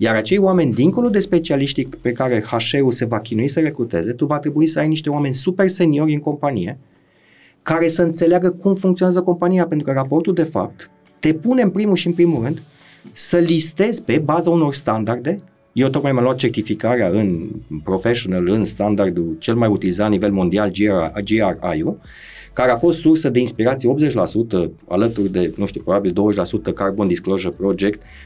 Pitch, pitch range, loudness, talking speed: 140 Hz, 110-170 Hz, -18 LUFS, 175 wpm